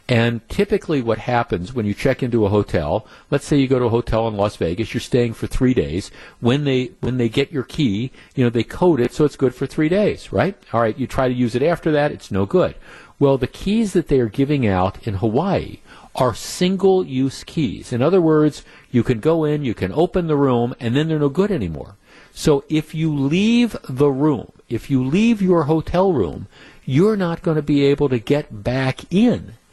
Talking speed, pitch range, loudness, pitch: 220 wpm, 120-160 Hz, -19 LUFS, 135 Hz